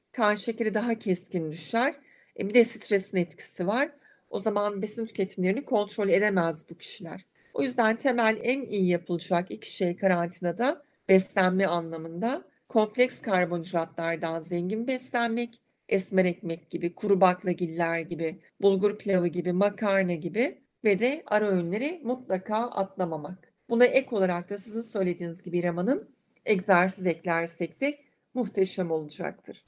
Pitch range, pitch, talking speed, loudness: 175-230 Hz, 195 Hz, 125 wpm, -28 LUFS